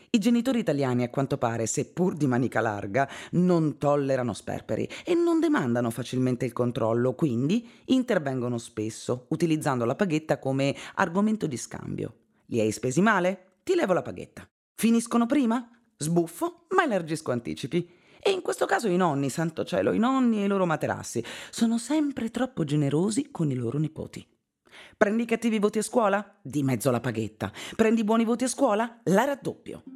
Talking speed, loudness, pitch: 165 wpm, -26 LUFS, 170 Hz